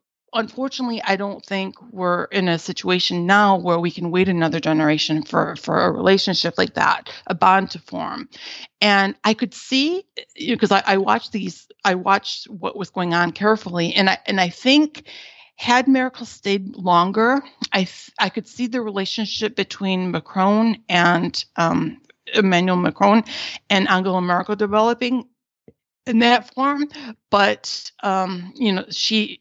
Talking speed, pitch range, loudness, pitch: 155 wpm, 185-235 Hz, -19 LUFS, 200 Hz